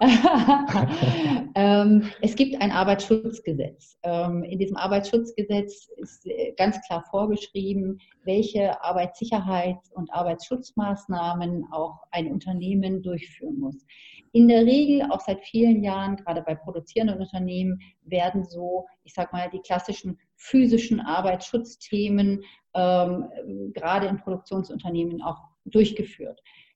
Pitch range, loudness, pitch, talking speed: 180-215 Hz, -24 LUFS, 195 Hz, 100 wpm